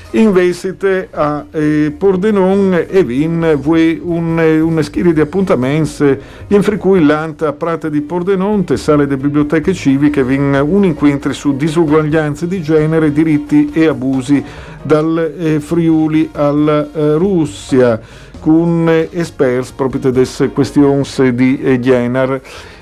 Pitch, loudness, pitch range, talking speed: 155 Hz, -13 LUFS, 140-165 Hz, 125 wpm